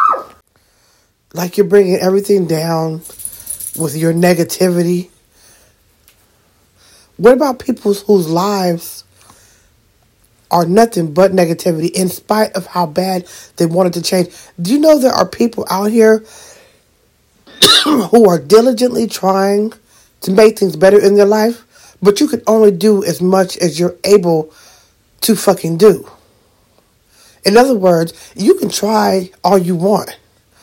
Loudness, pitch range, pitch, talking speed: -12 LUFS, 165-210 Hz, 185 Hz, 130 wpm